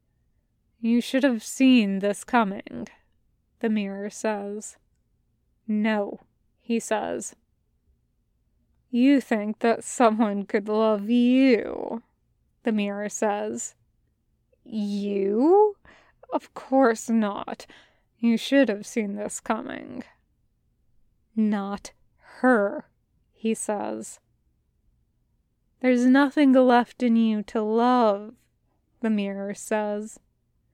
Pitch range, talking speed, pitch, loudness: 205-245 Hz, 90 wpm, 225 Hz, -24 LUFS